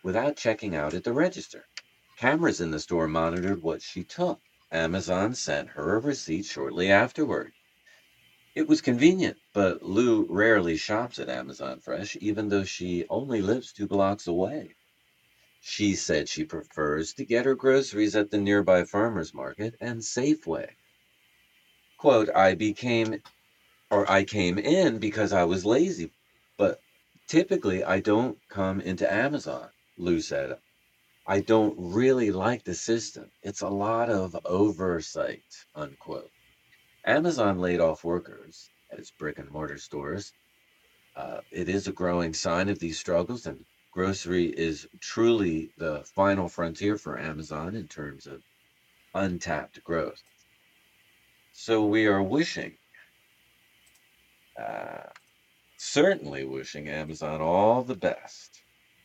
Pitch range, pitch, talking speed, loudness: 85-110 Hz, 95 Hz, 130 wpm, -27 LUFS